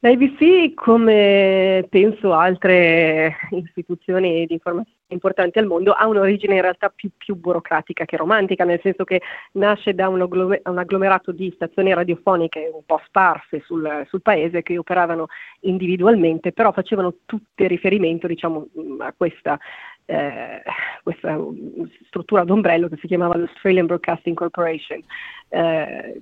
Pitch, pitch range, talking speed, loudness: 185 Hz, 170-195 Hz, 130 wpm, -18 LUFS